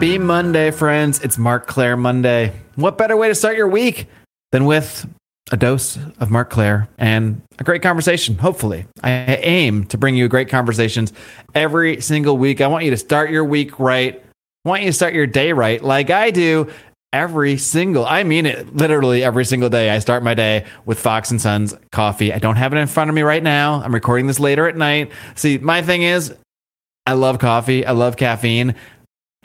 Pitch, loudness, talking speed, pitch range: 135 Hz, -16 LUFS, 200 wpm, 120-155 Hz